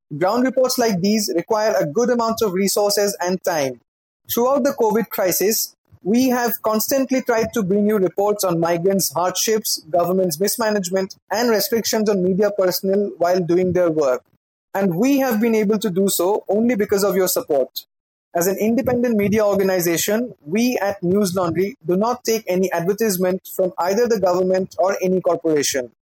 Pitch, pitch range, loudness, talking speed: 200 Hz, 185-225 Hz, -19 LUFS, 165 wpm